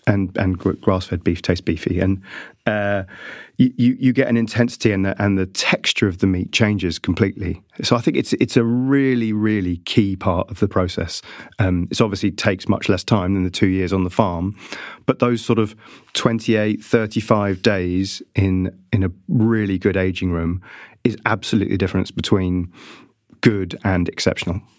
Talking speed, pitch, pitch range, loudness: 180 wpm, 100 Hz, 95-115 Hz, -20 LUFS